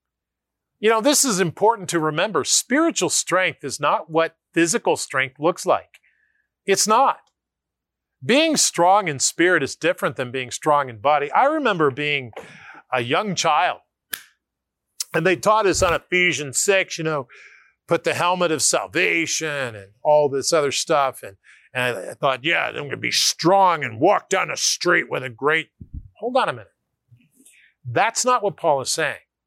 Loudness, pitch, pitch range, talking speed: -20 LUFS, 165 Hz, 145-195 Hz, 165 wpm